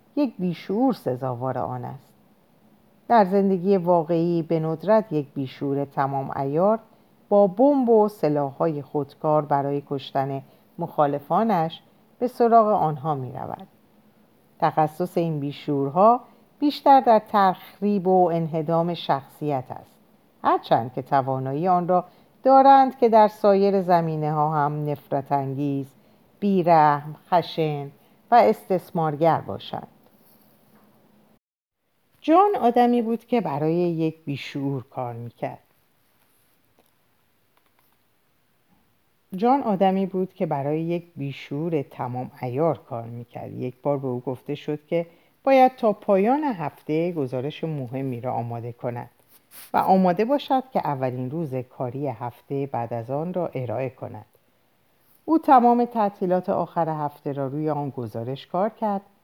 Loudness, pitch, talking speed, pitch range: -23 LUFS, 160 Hz, 120 wpm, 140-200 Hz